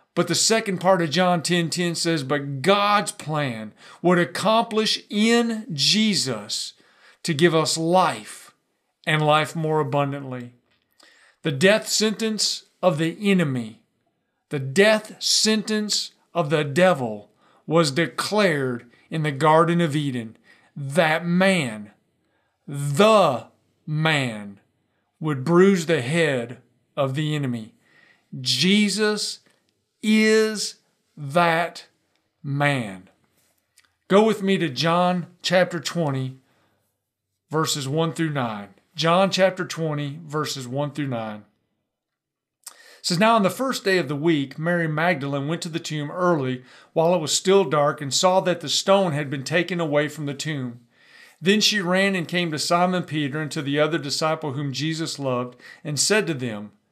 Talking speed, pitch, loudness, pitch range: 135 wpm, 160 Hz, -22 LUFS, 140-185 Hz